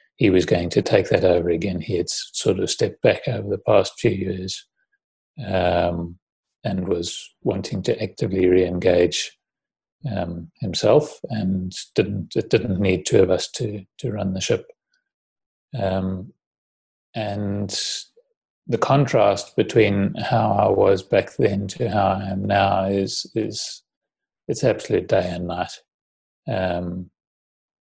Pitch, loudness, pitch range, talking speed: 95 Hz, -22 LUFS, 90-125 Hz, 135 wpm